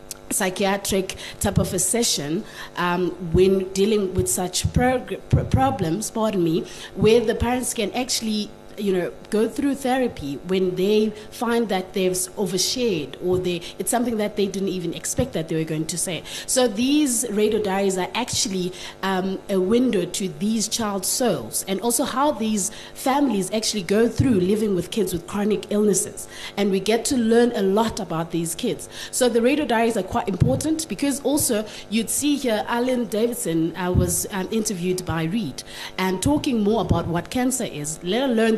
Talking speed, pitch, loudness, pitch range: 170 wpm, 205 Hz, -22 LUFS, 185-230 Hz